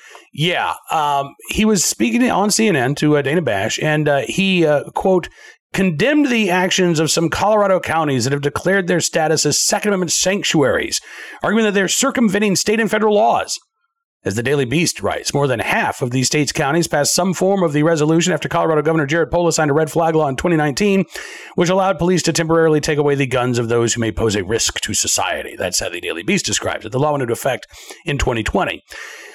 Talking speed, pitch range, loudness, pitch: 210 wpm, 145-195 Hz, -17 LUFS, 165 Hz